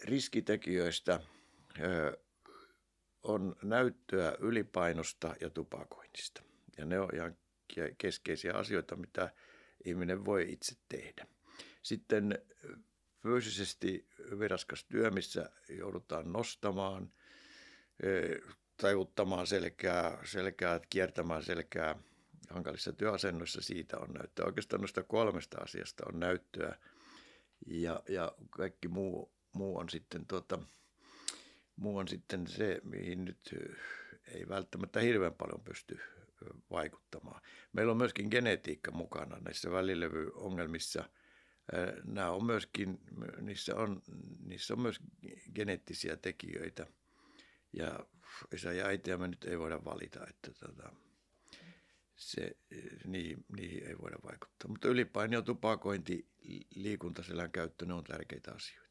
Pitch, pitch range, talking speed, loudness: 90 Hz, 85-100 Hz, 105 wpm, -39 LUFS